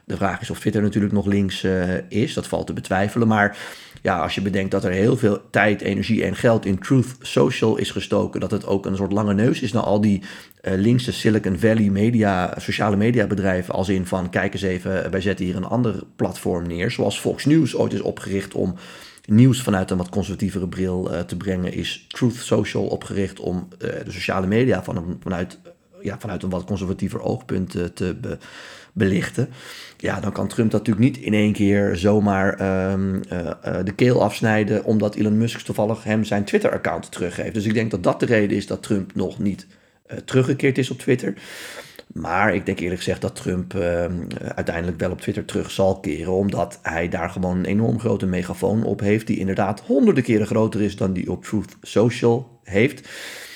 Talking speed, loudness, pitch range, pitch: 205 wpm, -21 LUFS, 95-110 Hz, 100 Hz